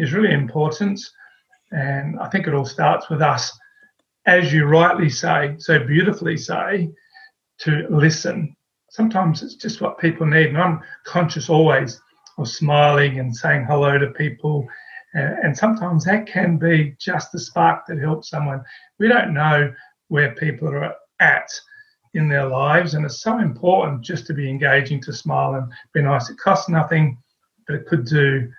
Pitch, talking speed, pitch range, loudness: 155 Hz, 165 wpm, 145-180 Hz, -19 LUFS